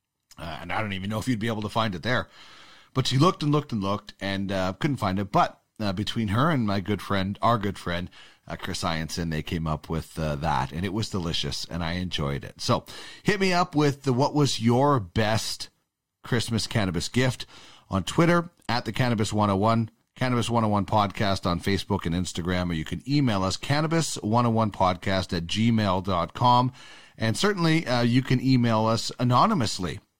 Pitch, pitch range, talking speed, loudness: 110 Hz, 95-125 Hz, 190 wpm, -25 LUFS